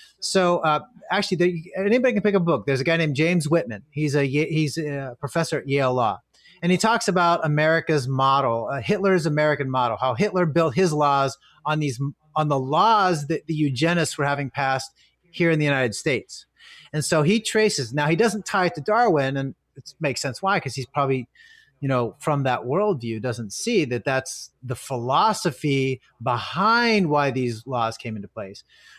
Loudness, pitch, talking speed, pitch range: -22 LUFS, 150 Hz, 190 wpm, 135-175 Hz